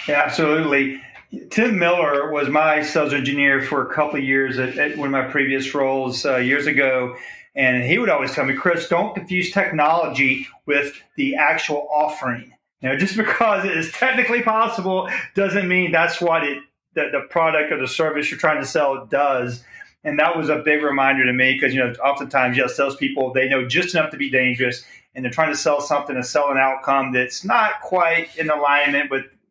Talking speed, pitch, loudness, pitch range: 200 wpm, 145 Hz, -19 LUFS, 135-165 Hz